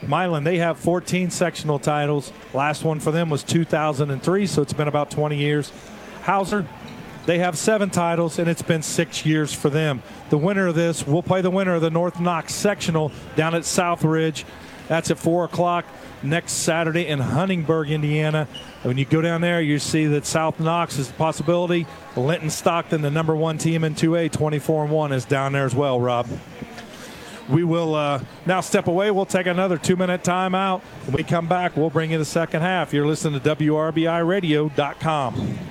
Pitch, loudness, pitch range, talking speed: 160 Hz, -22 LUFS, 150-175 Hz, 185 wpm